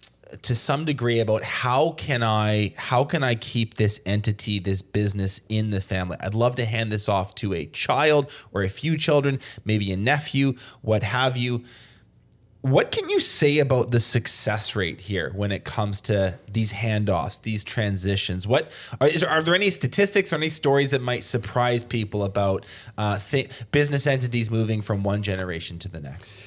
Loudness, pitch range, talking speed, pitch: -23 LUFS, 100-130 Hz, 180 wpm, 110 Hz